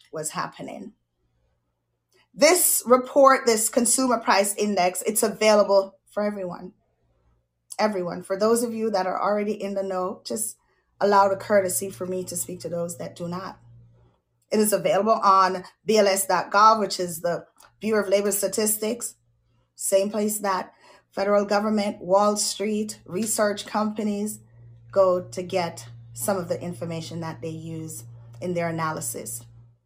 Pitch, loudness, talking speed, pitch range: 190 Hz, -23 LUFS, 140 wpm, 165-210 Hz